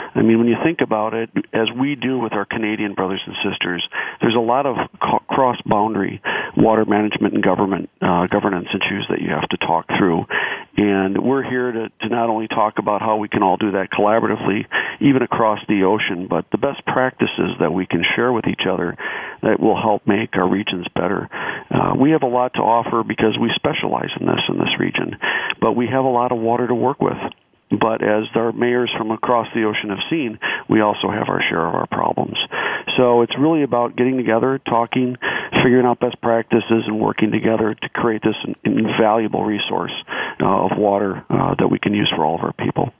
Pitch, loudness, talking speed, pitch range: 115 Hz, -18 LUFS, 205 wpm, 105-125 Hz